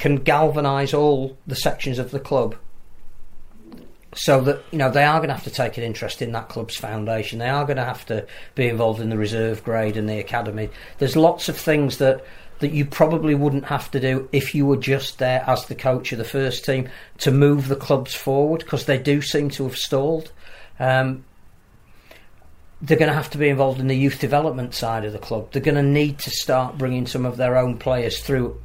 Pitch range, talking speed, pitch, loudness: 120-145 Hz, 220 wpm, 135 Hz, -21 LUFS